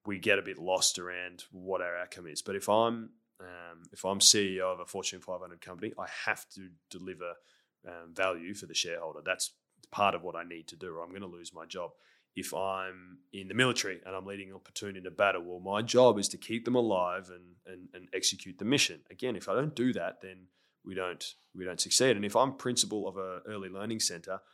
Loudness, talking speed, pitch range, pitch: -31 LUFS, 225 wpm, 90-105 Hz, 95 Hz